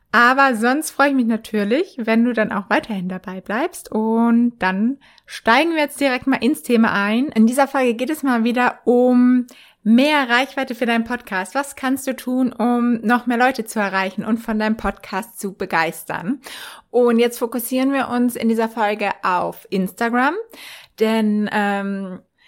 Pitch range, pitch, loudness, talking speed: 215-255 Hz, 240 Hz, -19 LUFS, 170 wpm